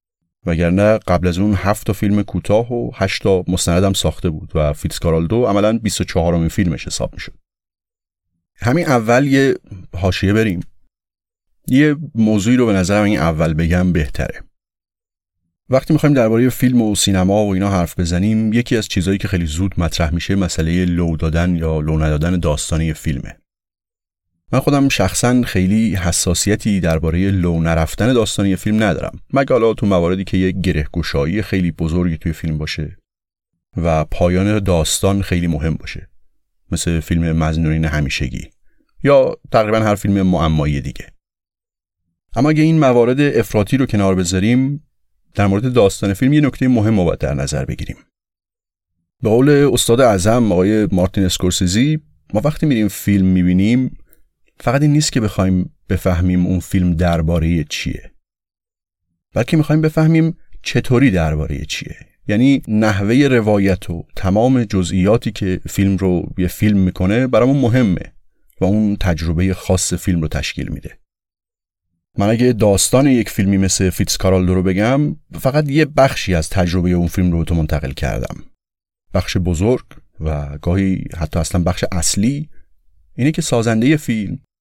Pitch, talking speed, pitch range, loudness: 95 Hz, 145 wpm, 85-115 Hz, -16 LUFS